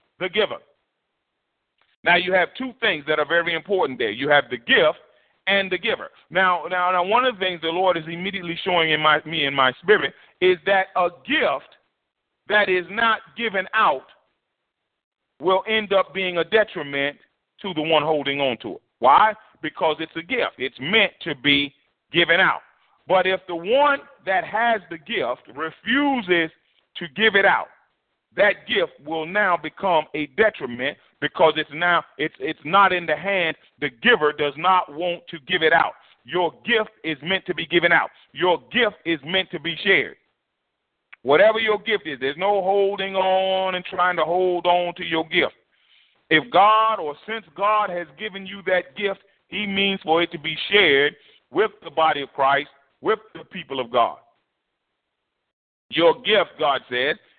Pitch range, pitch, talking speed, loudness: 160-200 Hz, 180 Hz, 180 wpm, -21 LUFS